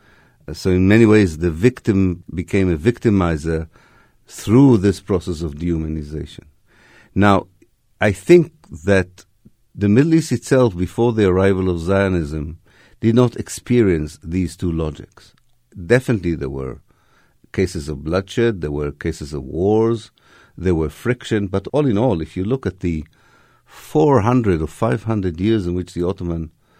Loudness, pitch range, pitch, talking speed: -18 LUFS, 85-115 Hz, 95 Hz, 145 wpm